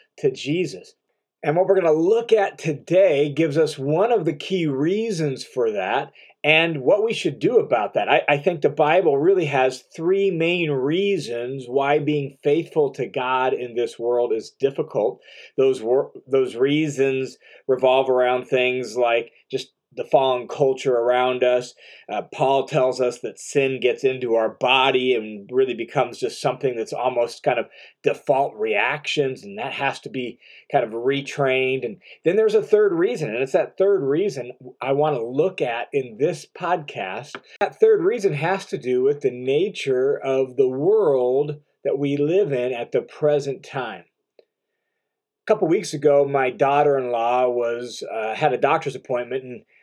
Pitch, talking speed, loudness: 145 Hz, 170 wpm, -21 LUFS